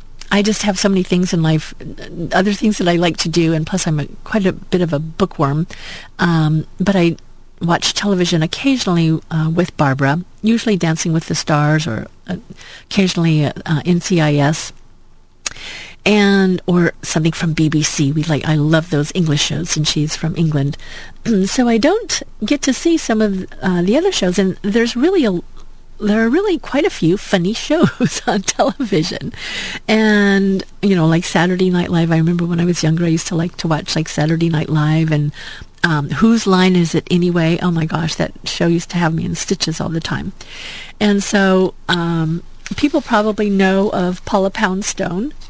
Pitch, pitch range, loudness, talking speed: 175 Hz, 160-200 Hz, -16 LUFS, 185 wpm